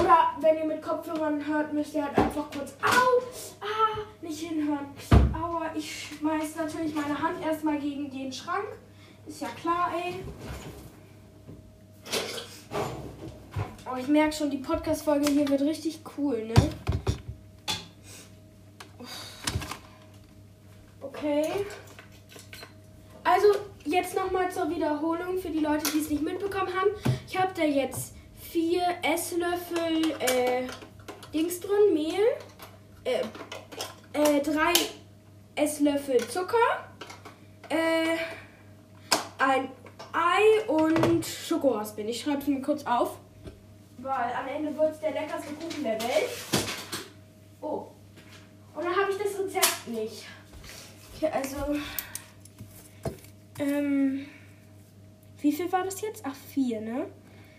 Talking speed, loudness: 115 wpm, -28 LUFS